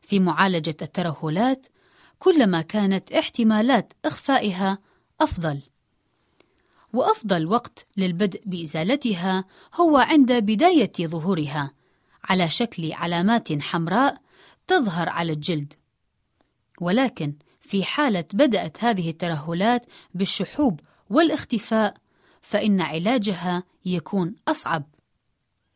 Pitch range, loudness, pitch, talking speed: 170-245 Hz, -22 LUFS, 195 Hz, 80 wpm